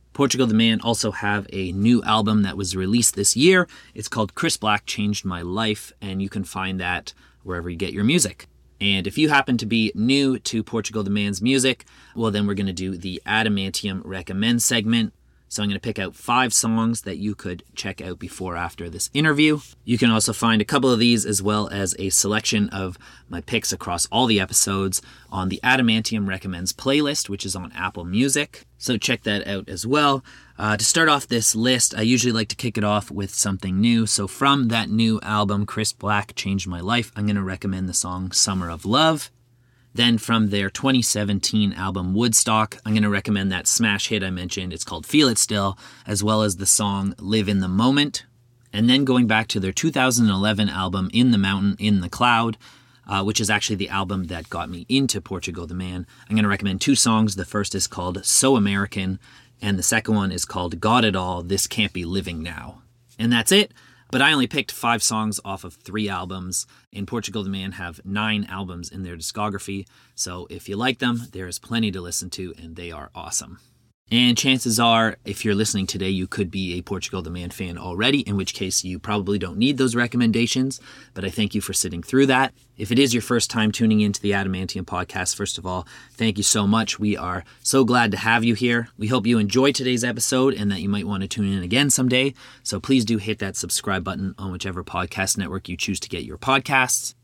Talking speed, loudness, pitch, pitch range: 215 wpm, -21 LUFS, 105 Hz, 95-120 Hz